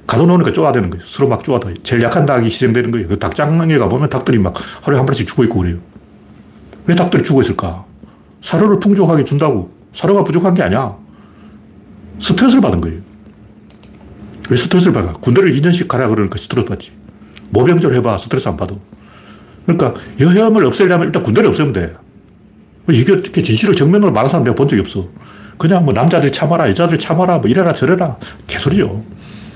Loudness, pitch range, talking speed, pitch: -13 LUFS, 105-175 Hz, 420 characters per minute, 135 Hz